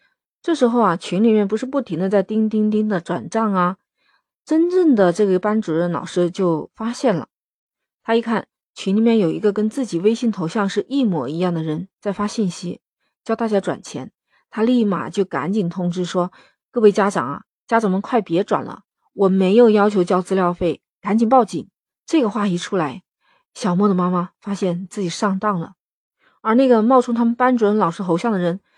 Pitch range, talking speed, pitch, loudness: 180-225 Hz, 280 characters per minute, 205 Hz, -19 LUFS